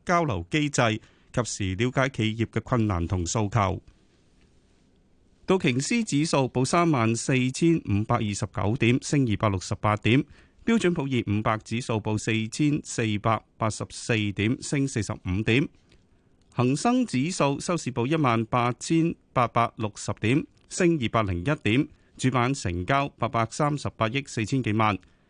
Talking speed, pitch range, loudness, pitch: 230 characters per minute, 105-140 Hz, -26 LUFS, 115 Hz